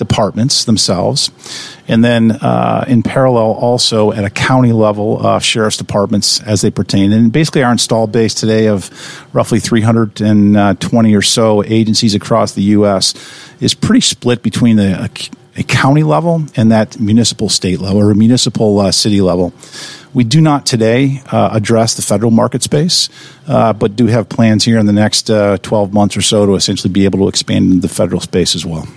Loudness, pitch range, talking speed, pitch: -11 LUFS, 105-120 Hz, 190 wpm, 110 Hz